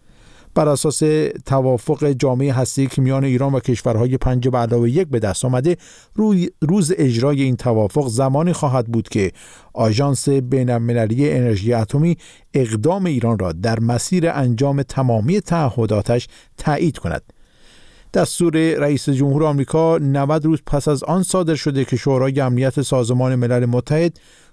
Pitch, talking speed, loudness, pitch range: 135 Hz, 140 wpm, -18 LUFS, 120-155 Hz